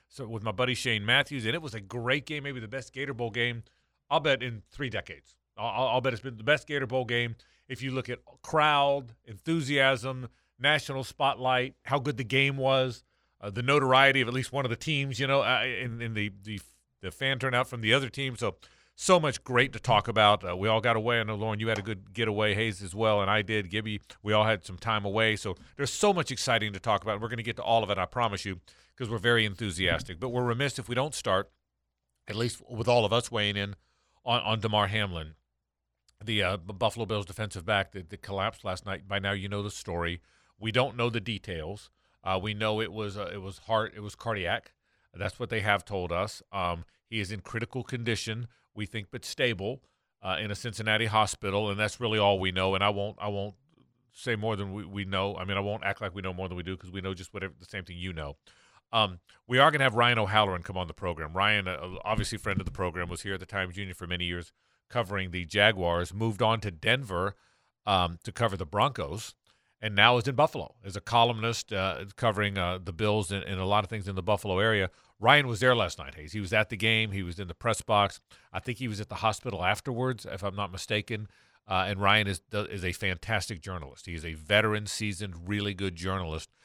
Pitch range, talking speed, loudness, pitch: 95-120 Hz, 240 wpm, -29 LUFS, 105 Hz